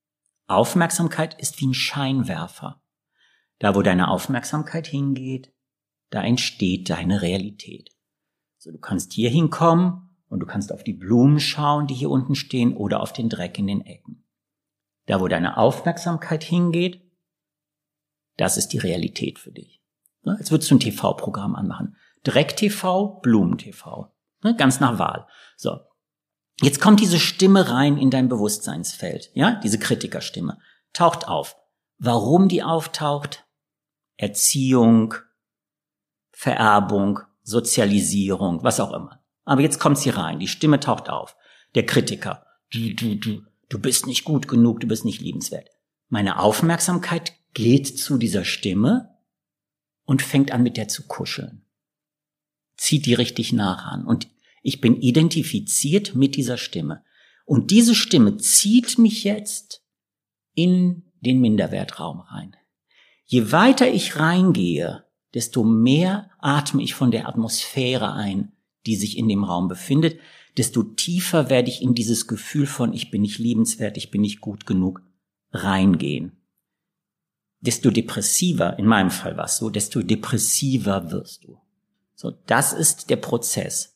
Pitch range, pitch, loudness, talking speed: 115-160 Hz, 135 Hz, -20 LUFS, 135 wpm